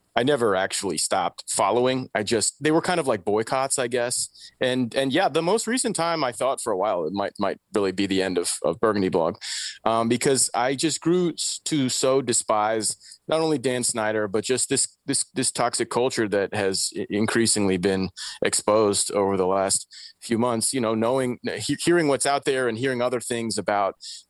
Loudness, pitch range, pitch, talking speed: -23 LUFS, 105-135 Hz, 120 Hz, 195 wpm